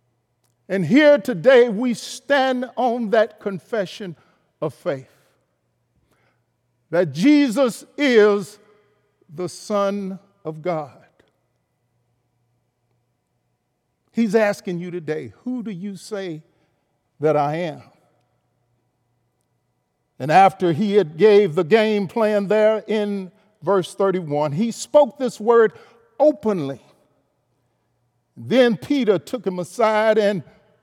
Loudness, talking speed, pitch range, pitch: -19 LUFS, 100 wpm, 145-220 Hz, 200 Hz